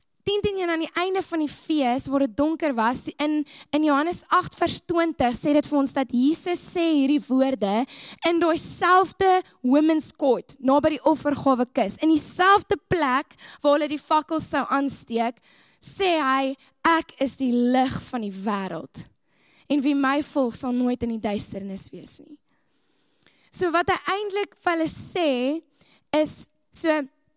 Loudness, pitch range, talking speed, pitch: -22 LUFS, 265-330 Hz, 160 wpm, 295 Hz